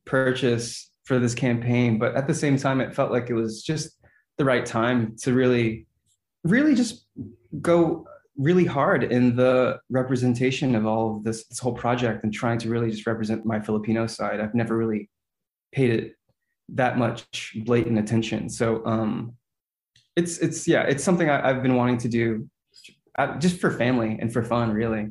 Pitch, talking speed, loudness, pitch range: 120 Hz, 175 wpm, -24 LUFS, 115-130 Hz